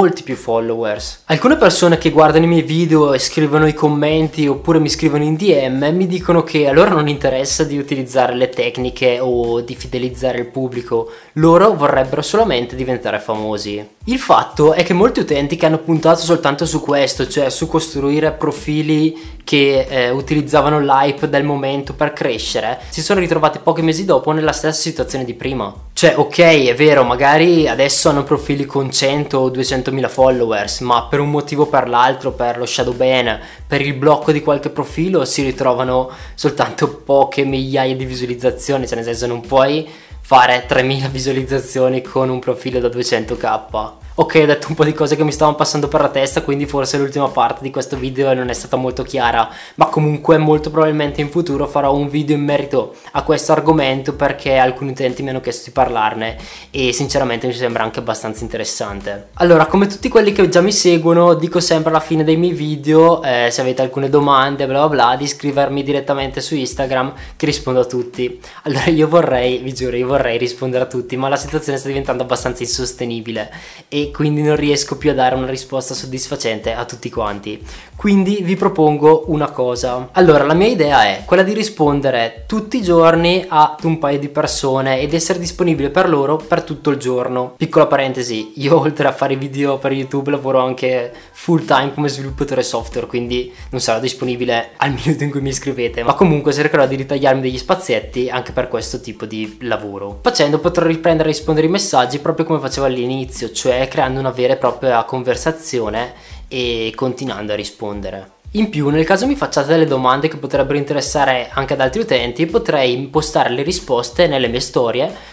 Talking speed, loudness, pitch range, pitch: 185 wpm, -15 LUFS, 125-155 Hz, 140 Hz